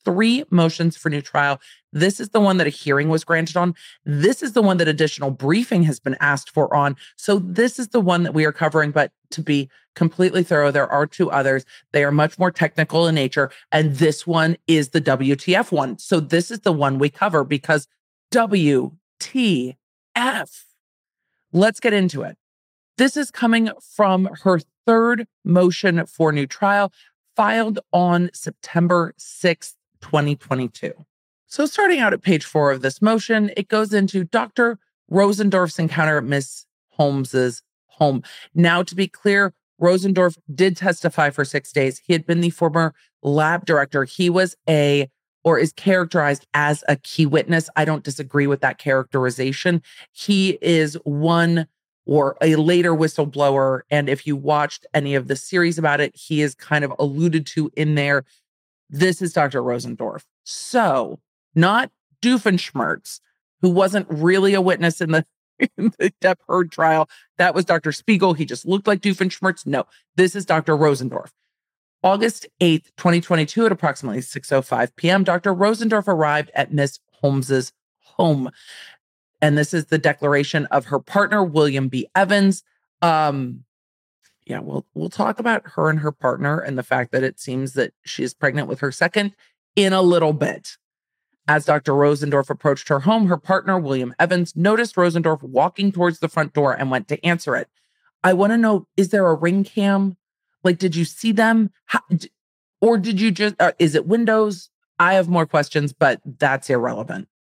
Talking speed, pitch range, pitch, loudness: 170 wpm, 145-190 Hz, 165 Hz, -19 LUFS